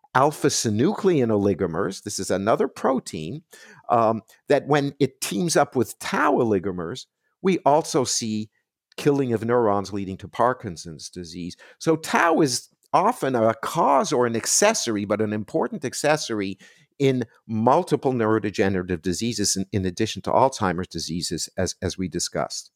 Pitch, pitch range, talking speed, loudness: 110 Hz, 95-135 Hz, 140 wpm, -23 LUFS